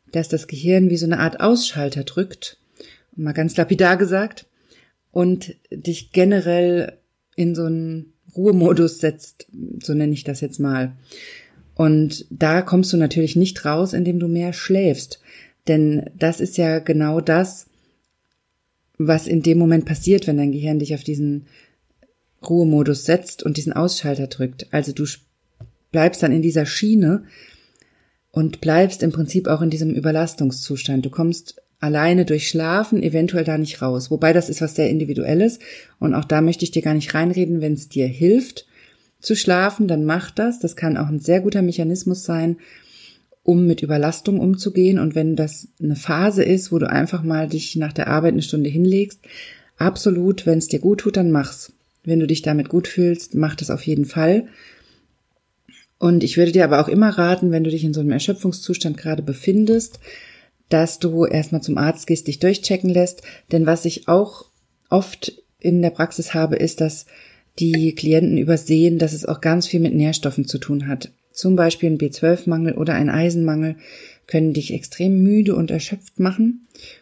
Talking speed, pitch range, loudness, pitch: 170 wpm, 155-180 Hz, -19 LUFS, 165 Hz